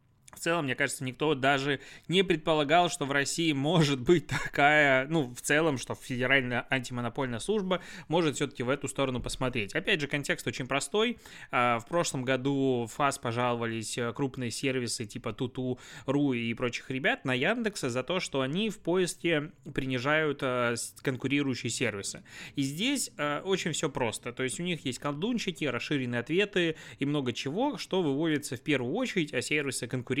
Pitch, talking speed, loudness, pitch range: 140 Hz, 160 wpm, -29 LUFS, 125-160 Hz